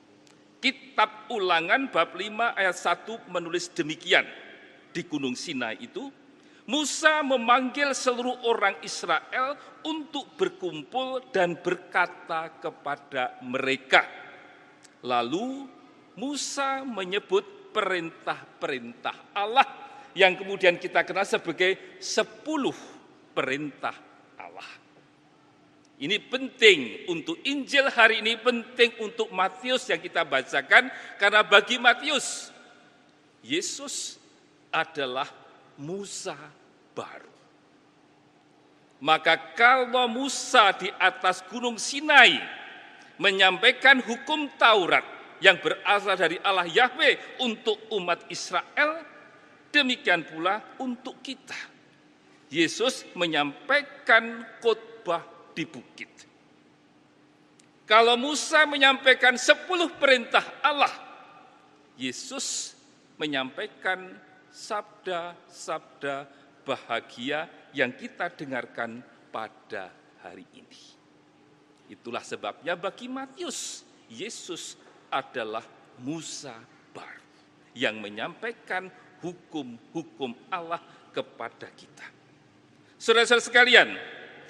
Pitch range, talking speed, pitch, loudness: 175-270 Hz, 80 wpm, 225 Hz, -25 LUFS